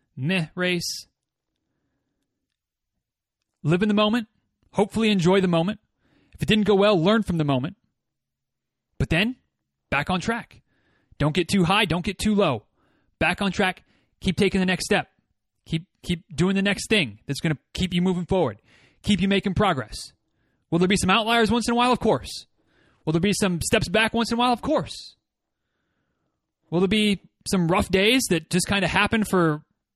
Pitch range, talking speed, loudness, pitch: 160-210 Hz, 180 wpm, -23 LUFS, 185 Hz